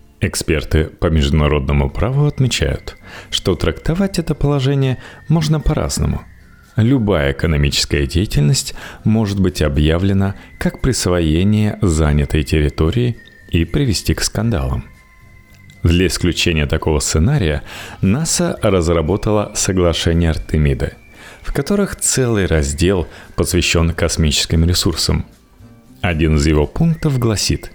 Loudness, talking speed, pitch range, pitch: -16 LUFS, 95 wpm, 80-115 Hz, 90 Hz